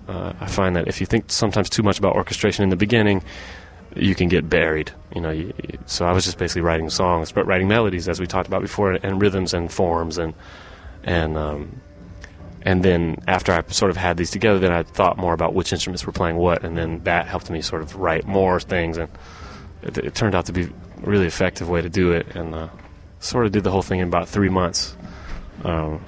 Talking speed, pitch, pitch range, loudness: 235 wpm, 90 Hz, 85-95 Hz, -21 LUFS